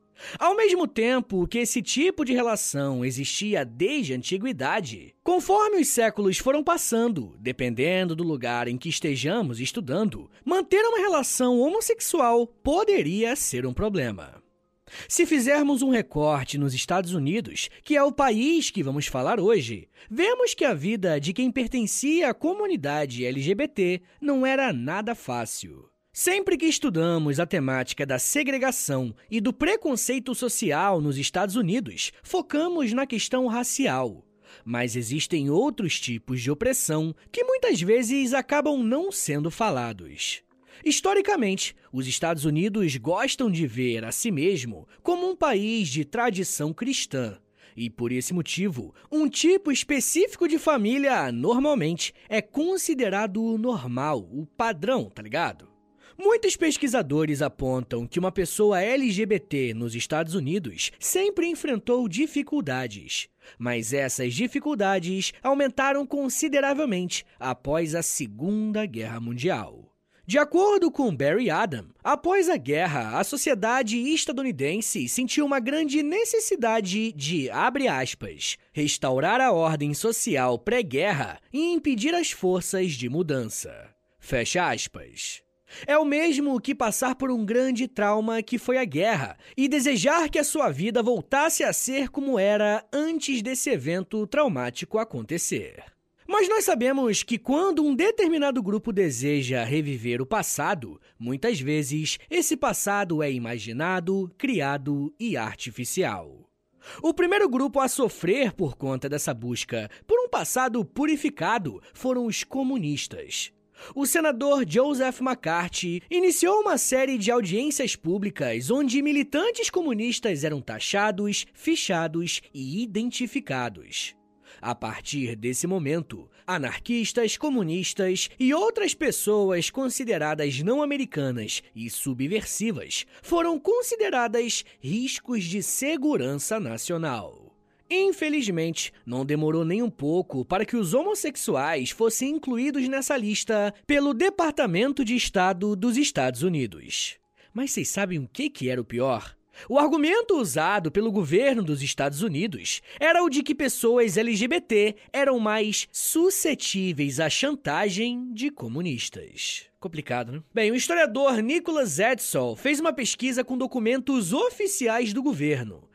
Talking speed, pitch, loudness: 125 wpm, 230 Hz, -25 LUFS